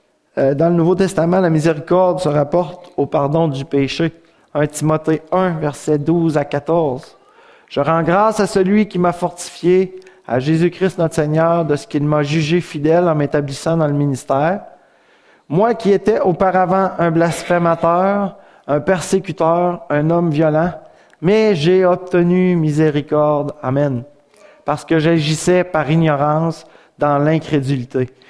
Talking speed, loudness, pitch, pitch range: 140 wpm, -16 LUFS, 165 Hz, 150-180 Hz